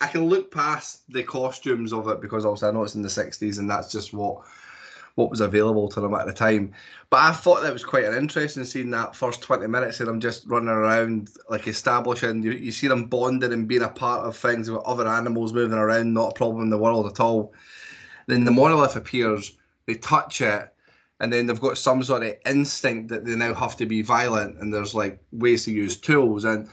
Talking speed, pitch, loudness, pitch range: 230 wpm, 115 Hz, -23 LUFS, 110-125 Hz